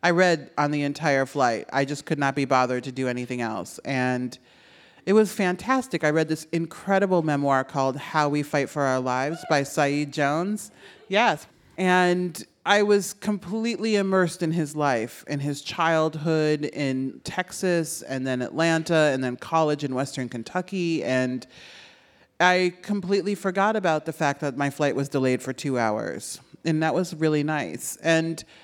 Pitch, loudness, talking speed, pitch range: 155 Hz, -24 LUFS, 165 wpm, 140-180 Hz